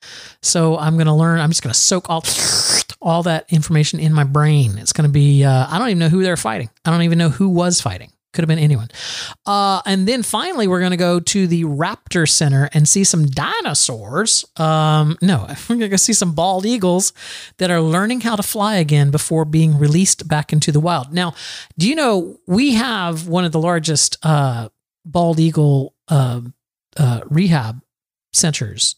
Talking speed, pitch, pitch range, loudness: 195 wpm, 165 Hz, 145-180 Hz, -16 LUFS